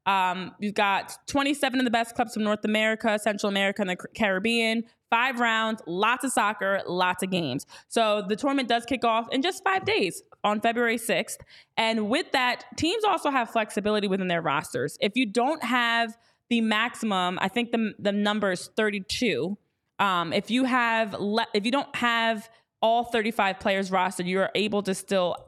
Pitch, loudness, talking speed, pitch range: 220 Hz, -26 LUFS, 185 wpm, 200-240 Hz